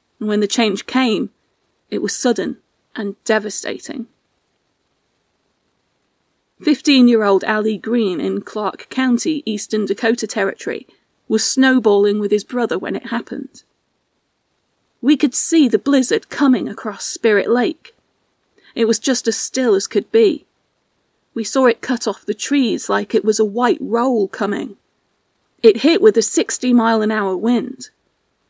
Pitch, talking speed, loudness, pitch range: 235 Hz, 145 wpm, -17 LUFS, 215-265 Hz